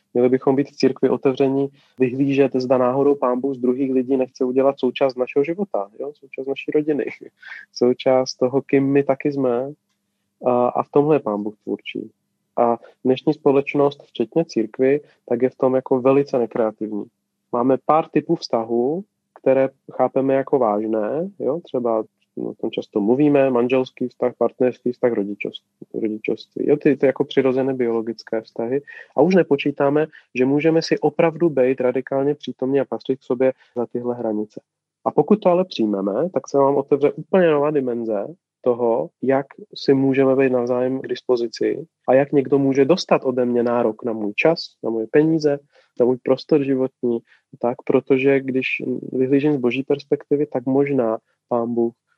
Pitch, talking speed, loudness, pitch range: 130 Hz, 160 wpm, -20 LUFS, 125-140 Hz